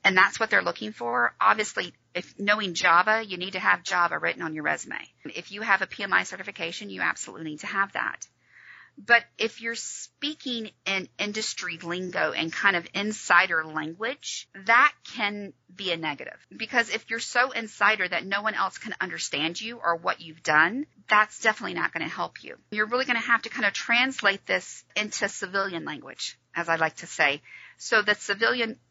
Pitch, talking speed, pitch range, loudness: 200 Hz, 185 wpm, 170-225 Hz, -25 LUFS